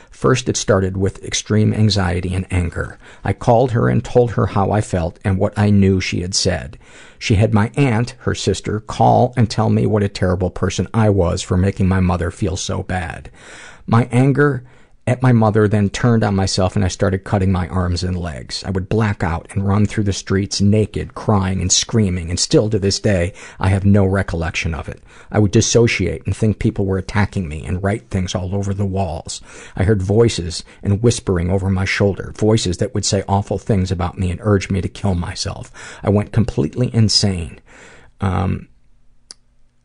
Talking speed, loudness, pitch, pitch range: 195 wpm, -17 LUFS, 100 Hz, 95-110 Hz